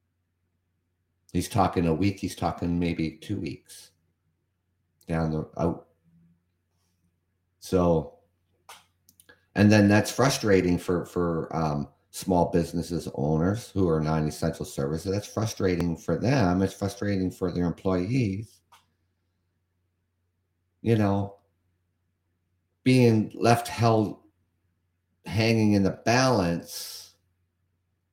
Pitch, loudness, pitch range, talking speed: 90 Hz, -26 LUFS, 85-95 Hz, 100 wpm